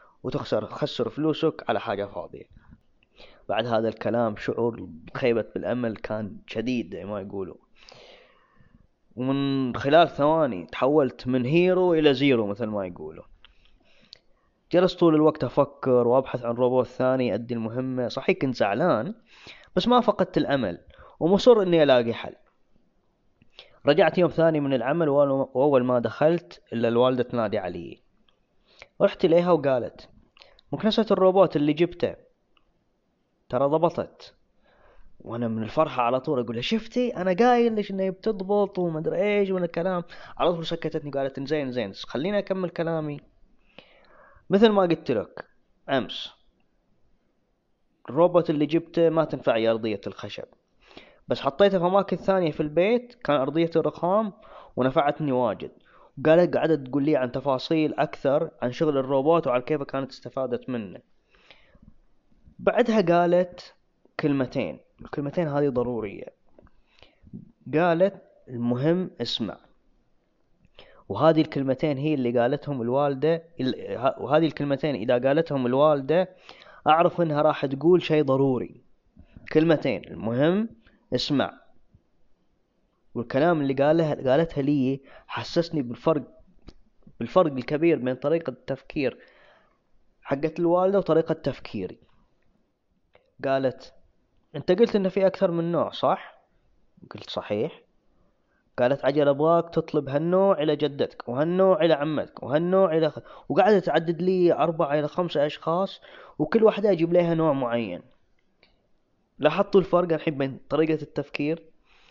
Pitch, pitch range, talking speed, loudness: 150 Hz, 130-175 Hz, 120 wpm, -24 LUFS